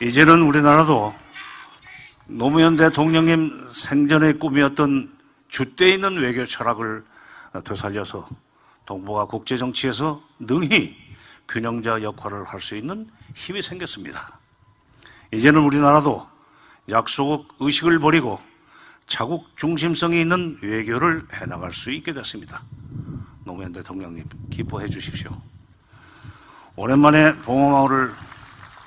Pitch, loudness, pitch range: 135 Hz, -19 LUFS, 110-155 Hz